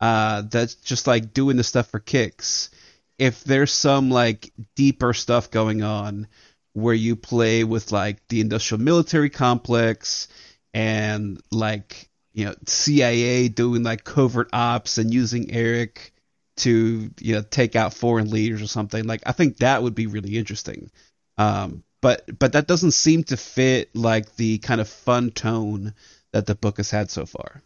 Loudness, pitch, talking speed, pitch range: -21 LUFS, 115 Hz, 165 wpm, 110-125 Hz